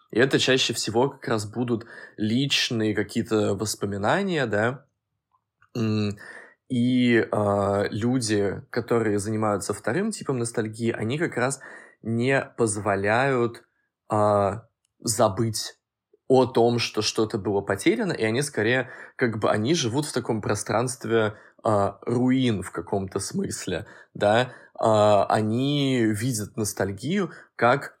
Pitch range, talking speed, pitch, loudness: 105-125 Hz, 115 wpm, 115 Hz, -24 LUFS